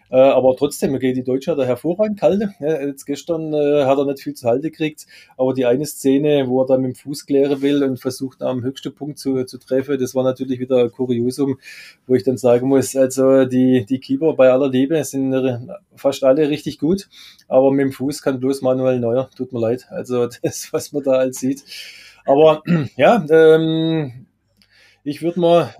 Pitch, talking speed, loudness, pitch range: 135 Hz, 200 wpm, -18 LUFS, 130-145 Hz